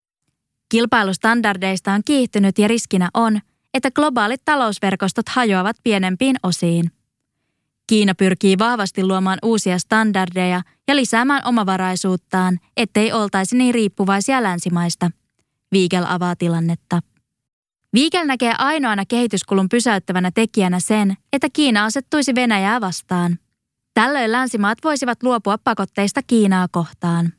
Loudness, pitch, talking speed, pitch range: -18 LUFS, 205 Hz, 105 wpm, 185-240 Hz